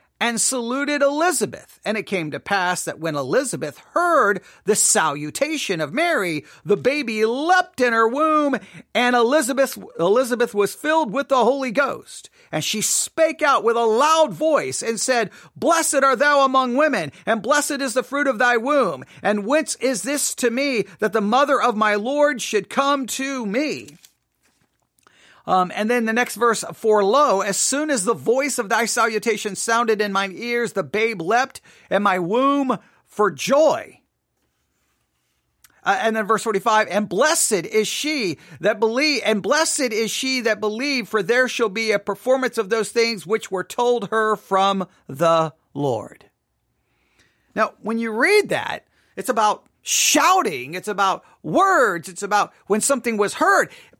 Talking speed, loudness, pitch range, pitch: 165 wpm, -20 LUFS, 210-275 Hz, 235 Hz